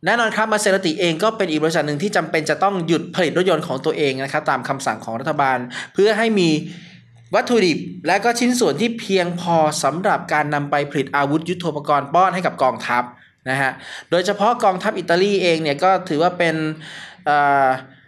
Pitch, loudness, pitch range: 165 Hz, -19 LUFS, 145-190 Hz